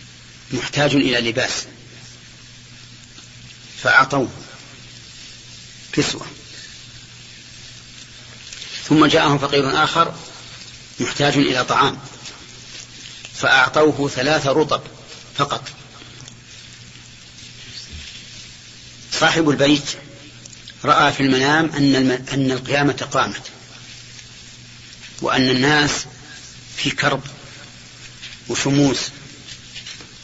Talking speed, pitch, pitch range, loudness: 60 wpm, 140 Hz, 125-145 Hz, -18 LUFS